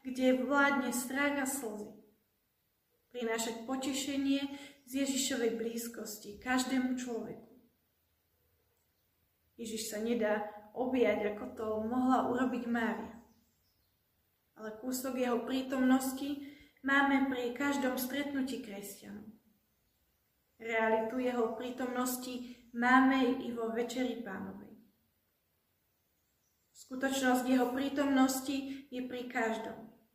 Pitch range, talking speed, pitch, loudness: 225-260 Hz, 85 wpm, 245 Hz, -34 LUFS